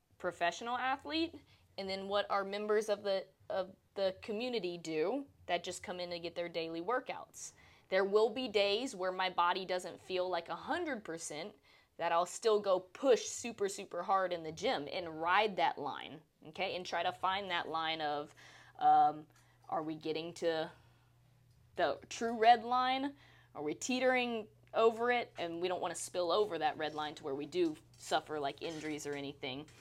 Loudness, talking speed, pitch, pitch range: -36 LUFS, 185 wpm, 180 Hz, 160-215 Hz